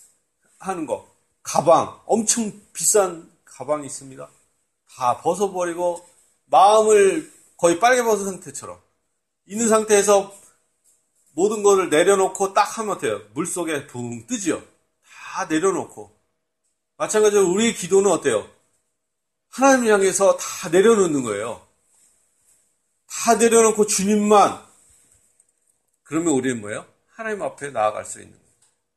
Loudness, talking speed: -19 LUFS, 260 characters per minute